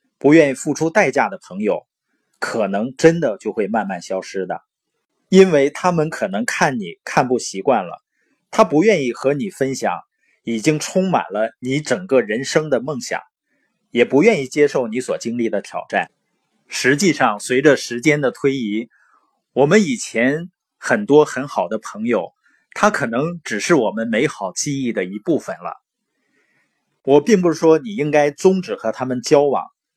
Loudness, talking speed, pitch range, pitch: -18 LUFS, 240 characters per minute, 130-185 Hz, 150 Hz